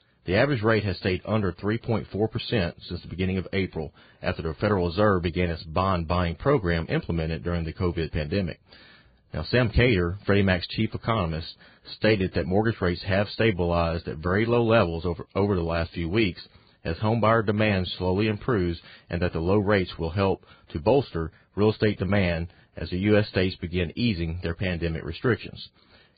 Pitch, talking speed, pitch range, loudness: 95 Hz, 175 wpm, 85-105 Hz, -26 LUFS